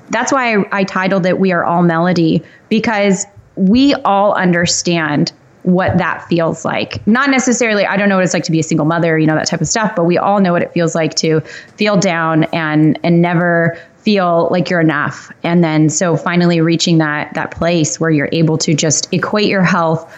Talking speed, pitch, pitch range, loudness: 210 wpm, 170 Hz, 165-195 Hz, -13 LUFS